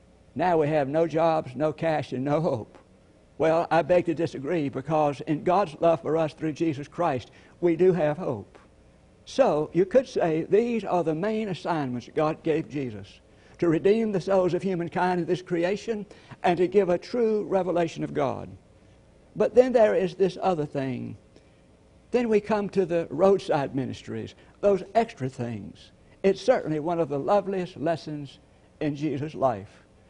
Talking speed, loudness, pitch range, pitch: 165 wpm, -26 LUFS, 150-190 Hz, 165 Hz